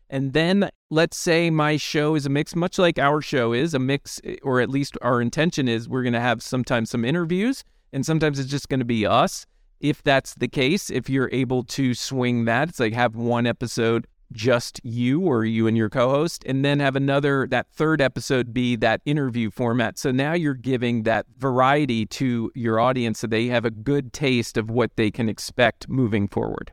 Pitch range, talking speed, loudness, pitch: 120-140 Hz, 210 wpm, -22 LUFS, 130 Hz